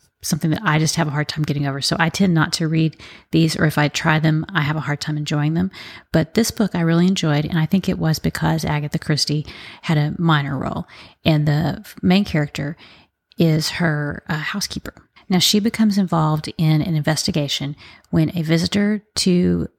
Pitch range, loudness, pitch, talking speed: 150-170 Hz, -19 LUFS, 160 Hz, 200 wpm